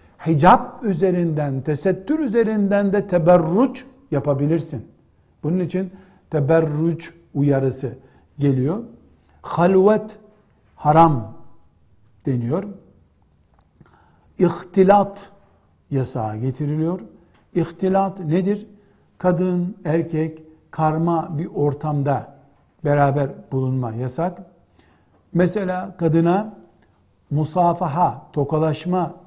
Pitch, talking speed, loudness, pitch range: 165 Hz, 65 wpm, -20 LUFS, 140-185 Hz